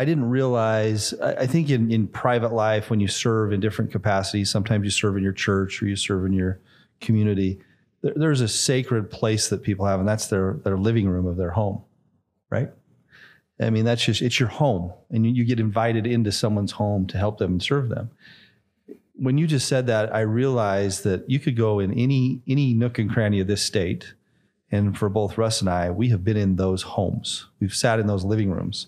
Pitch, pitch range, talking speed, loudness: 110 Hz, 100-120 Hz, 215 wpm, -23 LUFS